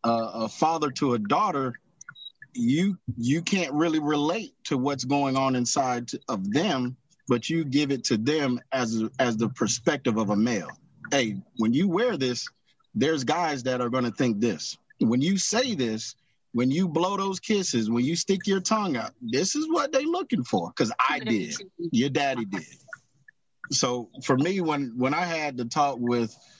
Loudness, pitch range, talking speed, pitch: -26 LUFS, 120-180 Hz, 185 wpm, 140 Hz